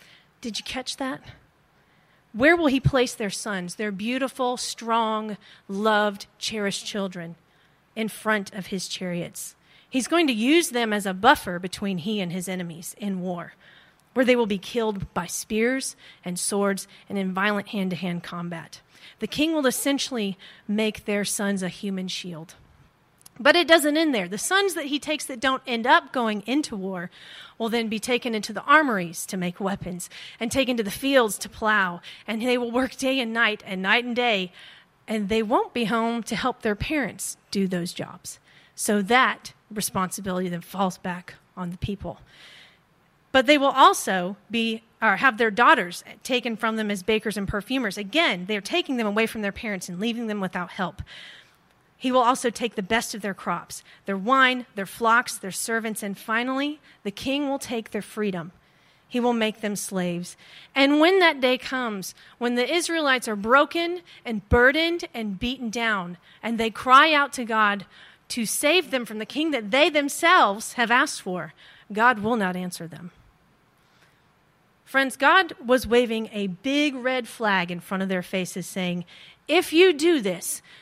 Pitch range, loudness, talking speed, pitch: 195-255 Hz, -24 LUFS, 180 wpm, 220 Hz